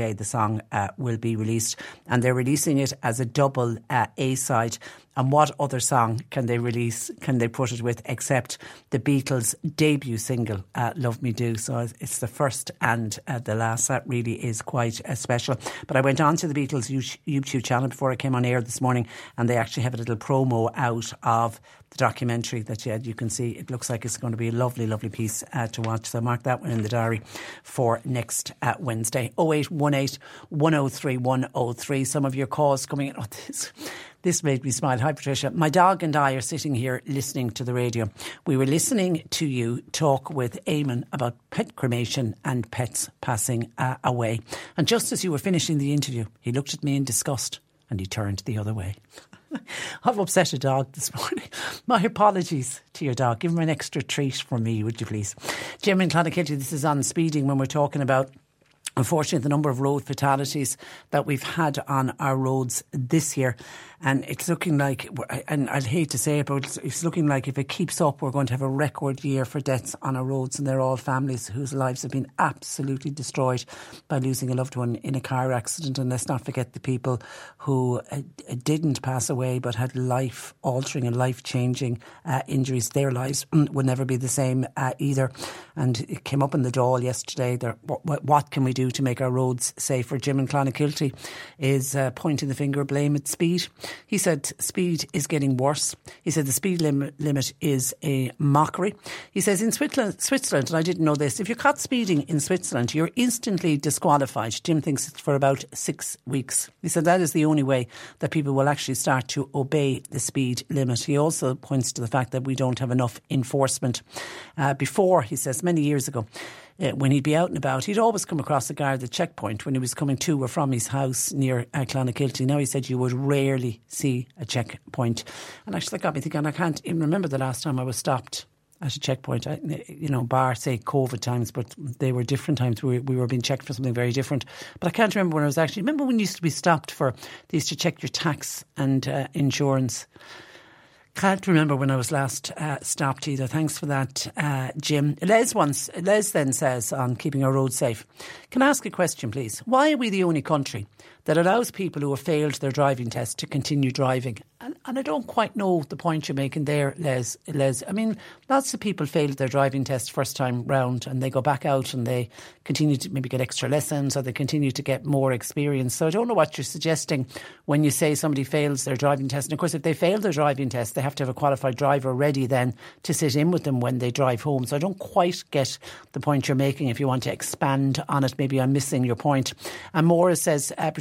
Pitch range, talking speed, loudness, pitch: 125-150 Hz, 220 wpm, -25 LUFS, 135 Hz